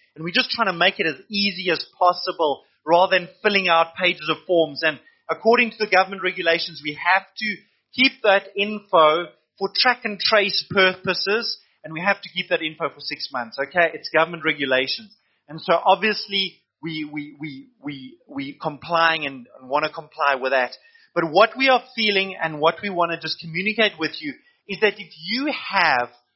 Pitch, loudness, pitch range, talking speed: 180 Hz, -21 LUFS, 155-205 Hz, 190 wpm